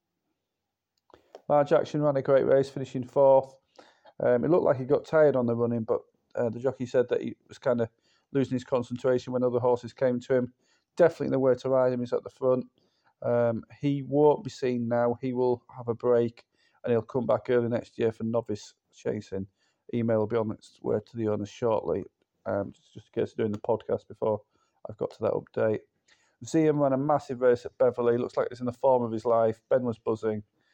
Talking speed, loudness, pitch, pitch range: 220 wpm, -27 LUFS, 125 Hz, 115-135 Hz